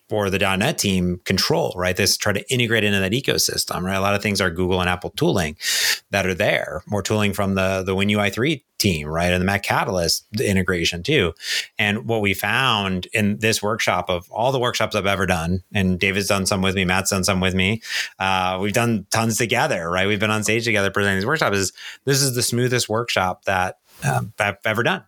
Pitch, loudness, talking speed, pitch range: 100 Hz, -20 LUFS, 225 wpm, 95-110 Hz